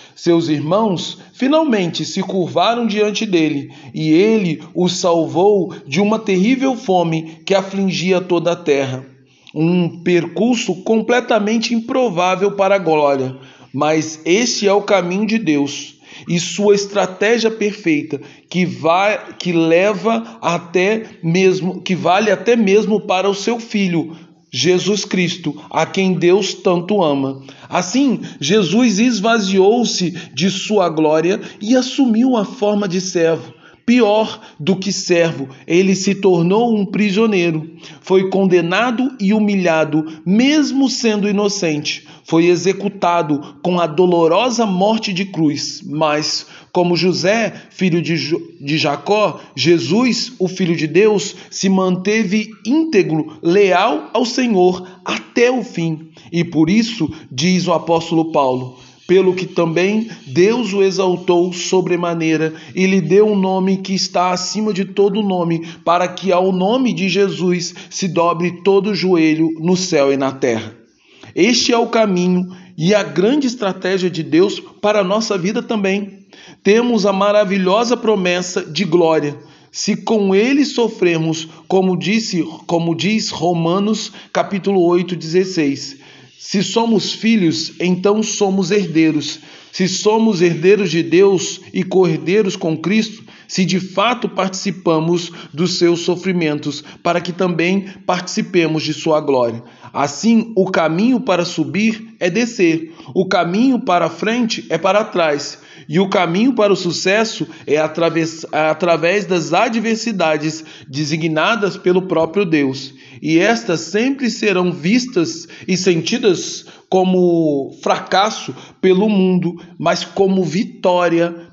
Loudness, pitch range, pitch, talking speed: -16 LUFS, 165-205 Hz, 185 Hz, 130 wpm